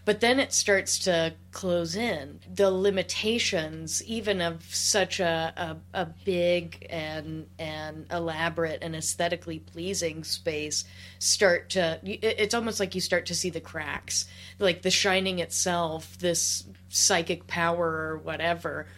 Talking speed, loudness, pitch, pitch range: 135 wpm, -27 LUFS, 170 Hz, 160-190 Hz